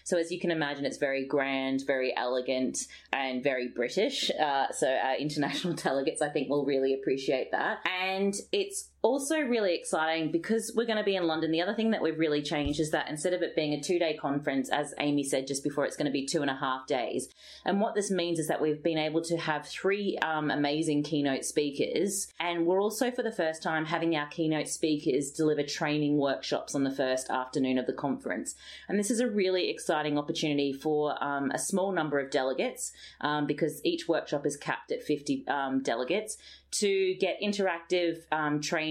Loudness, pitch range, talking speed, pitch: -30 LUFS, 145-175 Hz, 205 wpm, 155 Hz